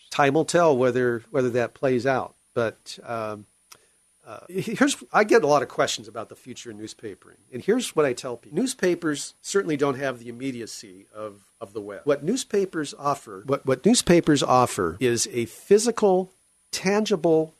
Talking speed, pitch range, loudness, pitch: 170 wpm, 120-185 Hz, -23 LUFS, 145 Hz